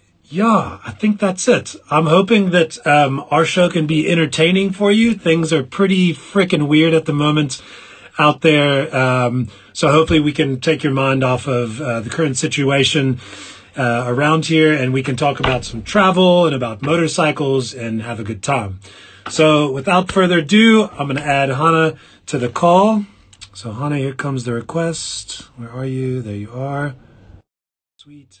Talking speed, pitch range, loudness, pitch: 175 wpm, 125-165 Hz, -16 LUFS, 145 Hz